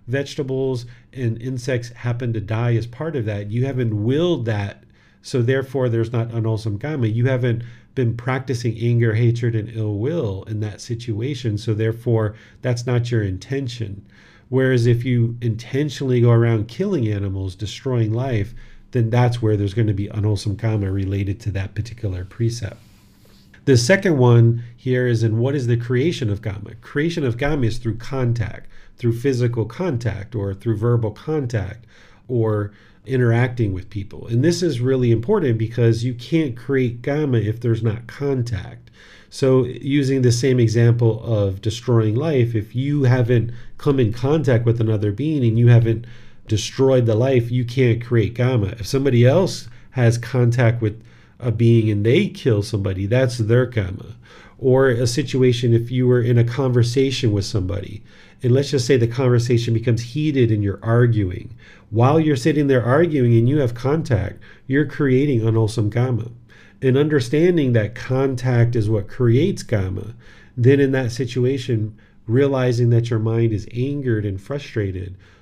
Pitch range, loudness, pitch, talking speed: 110-130 Hz, -20 LUFS, 120 Hz, 160 wpm